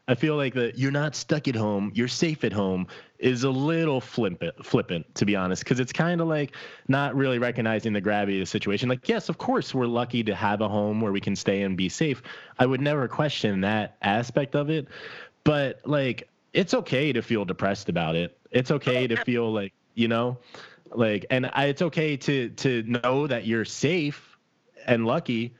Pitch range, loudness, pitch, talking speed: 110-140 Hz, -26 LUFS, 125 Hz, 205 wpm